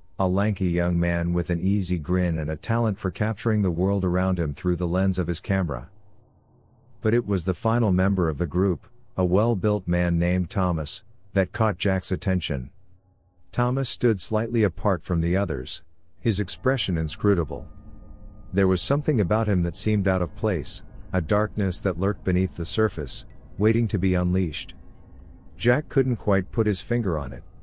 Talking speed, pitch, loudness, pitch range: 175 wpm, 95 Hz, -25 LUFS, 90-105 Hz